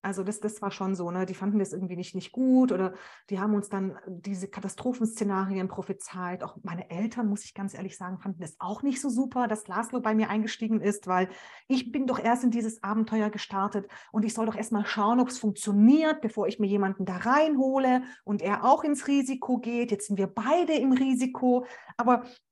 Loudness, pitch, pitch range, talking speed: -28 LUFS, 210 Hz, 195-250 Hz, 210 wpm